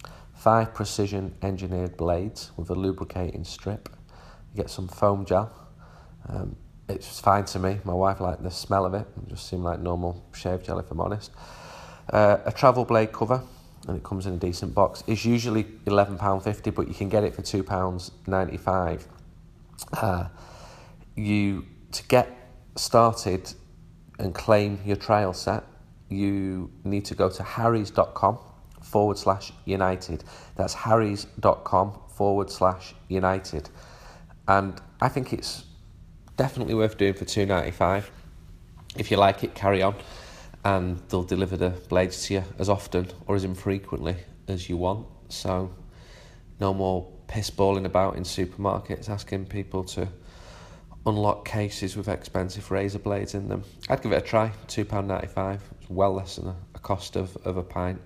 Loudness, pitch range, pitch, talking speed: -26 LUFS, 90-105 Hz, 95 Hz, 155 wpm